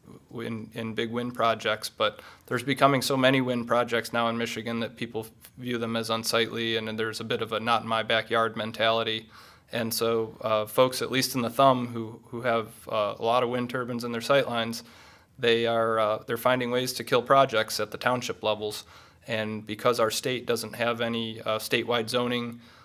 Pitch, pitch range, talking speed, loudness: 115 Hz, 110-120 Hz, 205 wpm, -27 LUFS